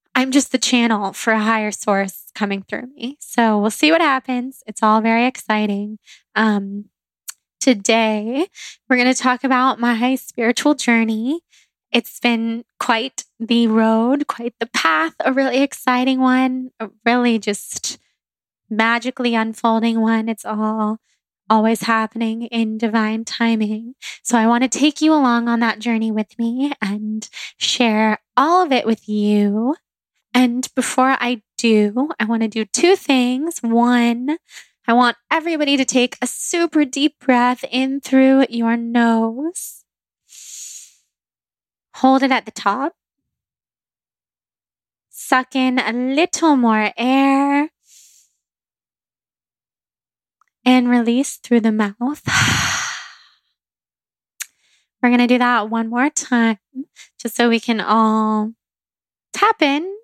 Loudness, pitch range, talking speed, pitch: -17 LUFS, 225-265 Hz, 130 wpm, 240 Hz